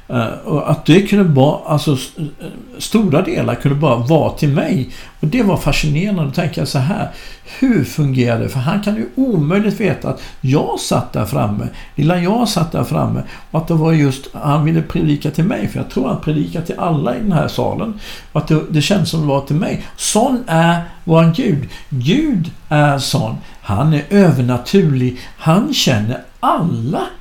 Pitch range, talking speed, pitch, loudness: 140-190 Hz, 190 wpm, 160 Hz, -16 LUFS